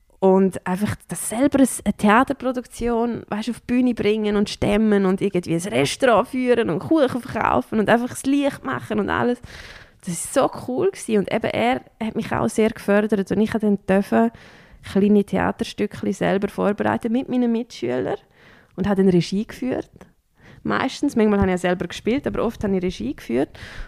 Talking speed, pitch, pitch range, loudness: 175 wpm, 215 Hz, 195-240 Hz, -21 LUFS